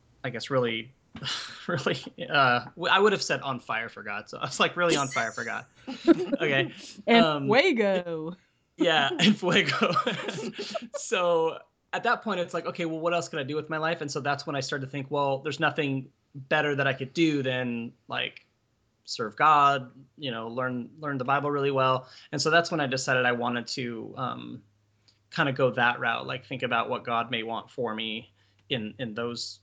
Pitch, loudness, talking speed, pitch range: 140 Hz, -27 LUFS, 205 wpm, 120-165 Hz